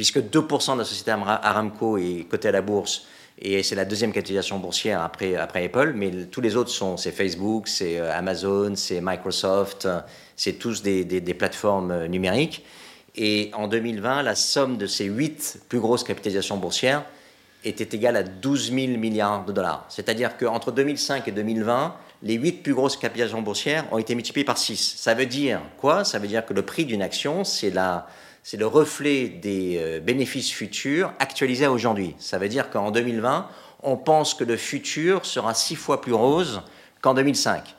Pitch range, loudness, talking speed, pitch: 100-135 Hz, -24 LUFS, 185 wpm, 115 Hz